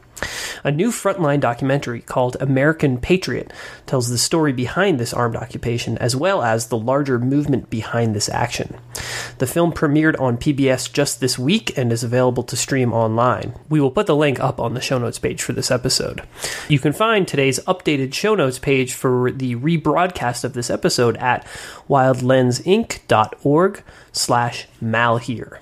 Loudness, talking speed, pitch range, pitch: -19 LUFS, 160 wpm, 120-150 Hz, 130 Hz